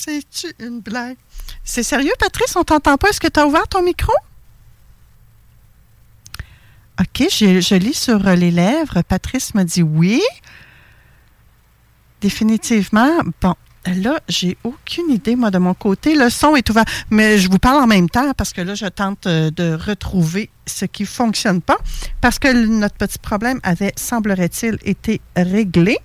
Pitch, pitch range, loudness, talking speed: 210 Hz, 180-250 Hz, -16 LUFS, 160 wpm